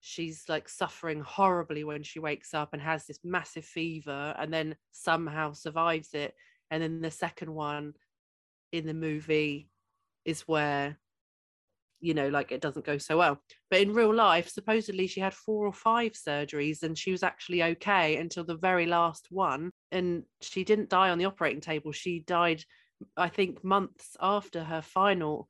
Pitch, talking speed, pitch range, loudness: 165 Hz, 170 wpm, 150-185 Hz, -30 LUFS